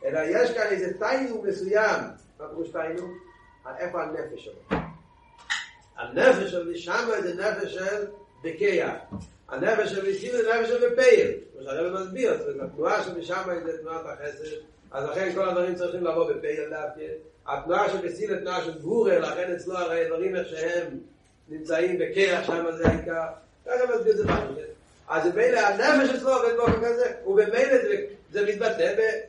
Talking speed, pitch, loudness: 160 wpm, 225 Hz, -26 LUFS